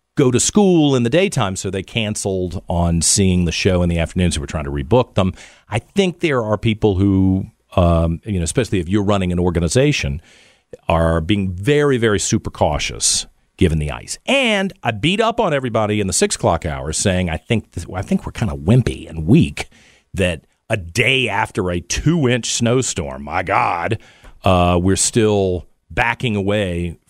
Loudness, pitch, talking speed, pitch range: -17 LUFS, 100 Hz, 180 wpm, 90-120 Hz